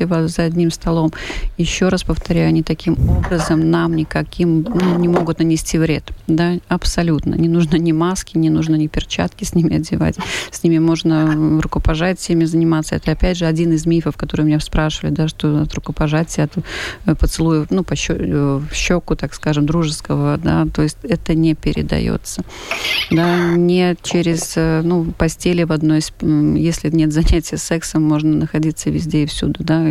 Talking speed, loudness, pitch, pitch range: 160 wpm, -17 LUFS, 160 Hz, 155-170 Hz